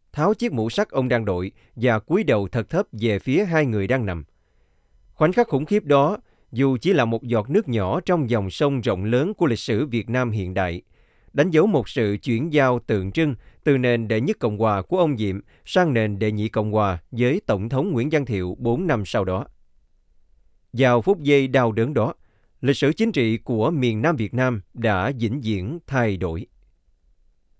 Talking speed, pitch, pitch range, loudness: 205 wpm, 120 Hz, 110-140 Hz, -22 LUFS